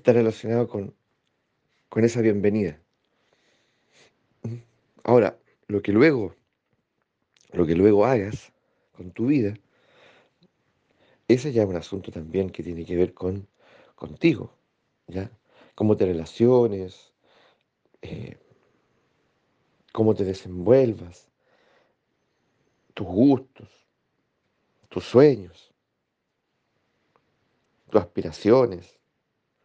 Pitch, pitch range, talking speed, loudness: 105 Hz, 95-115 Hz, 85 wpm, -23 LUFS